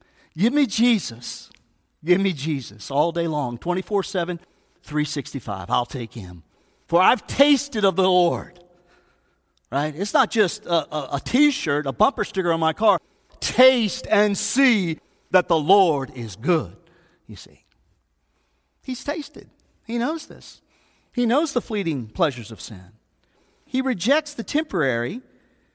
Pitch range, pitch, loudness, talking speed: 135-225 Hz, 175 Hz, -22 LUFS, 145 wpm